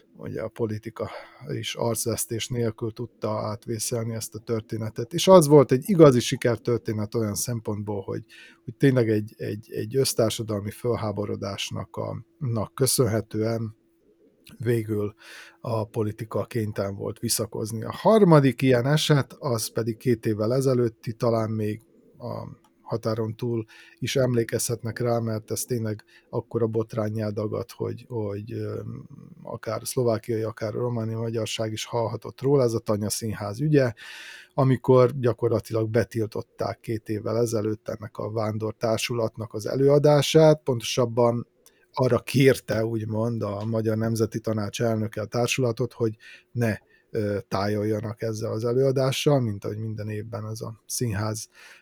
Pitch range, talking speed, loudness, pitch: 110-120 Hz, 125 wpm, -25 LUFS, 115 Hz